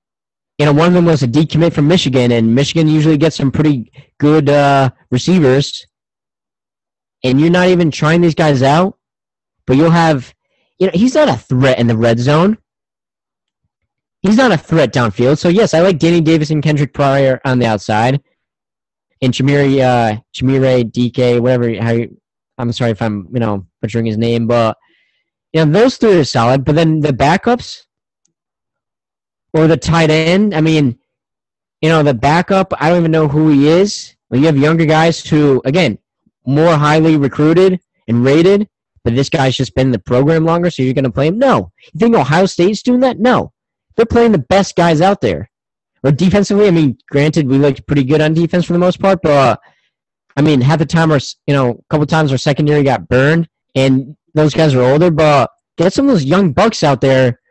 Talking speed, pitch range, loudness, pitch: 200 wpm, 130-170 Hz, -12 LUFS, 150 Hz